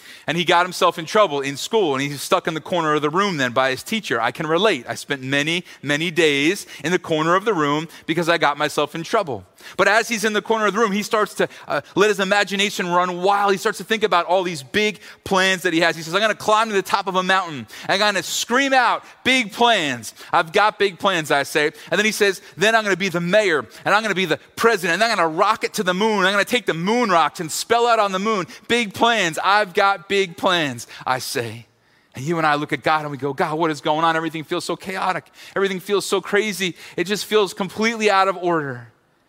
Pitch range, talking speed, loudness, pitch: 160-210 Hz, 265 wpm, -19 LUFS, 185 Hz